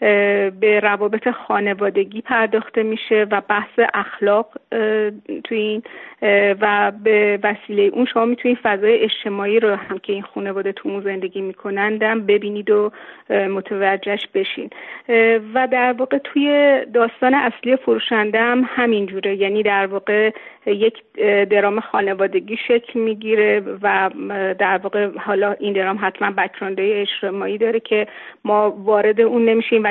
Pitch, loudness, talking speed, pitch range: 210 Hz, -18 LUFS, 125 wpm, 200-230 Hz